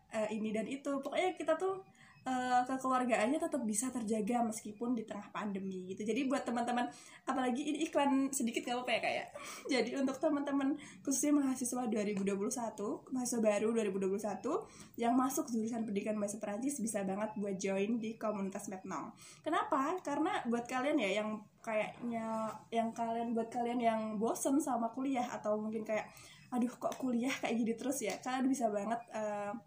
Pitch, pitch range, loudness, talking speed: 235 Hz, 215-270 Hz, -36 LUFS, 165 wpm